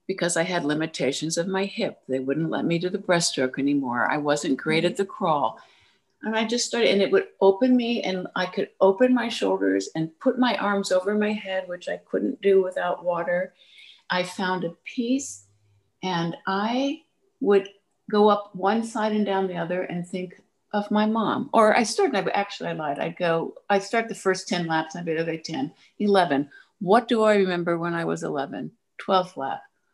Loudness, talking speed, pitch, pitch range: -24 LUFS, 200 wpm, 185 Hz, 170-210 Hz